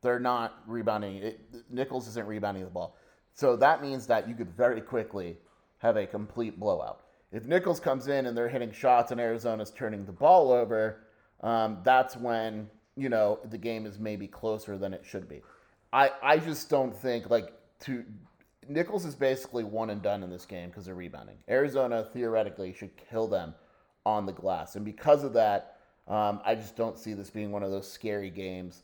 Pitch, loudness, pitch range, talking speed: 110 Hz, -30 LUFS, 105-125 Hz, 190 wpm